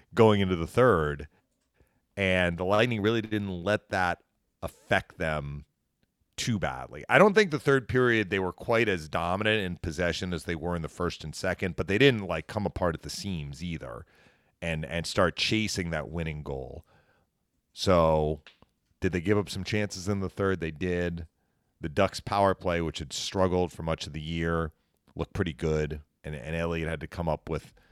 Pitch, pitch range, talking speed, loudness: 90 Hz, 80-100 Hz, 190 wpm, -28 LUFS